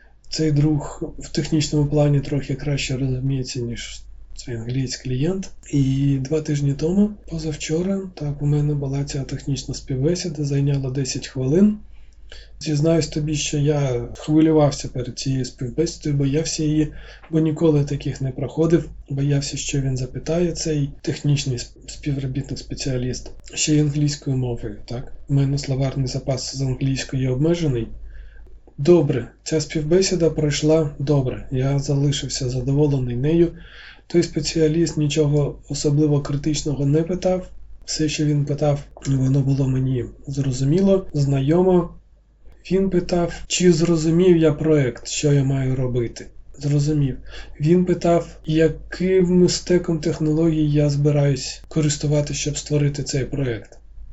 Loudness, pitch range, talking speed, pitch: -21 LUFS, 135-155 Hz, 120 wpm, 145 Hz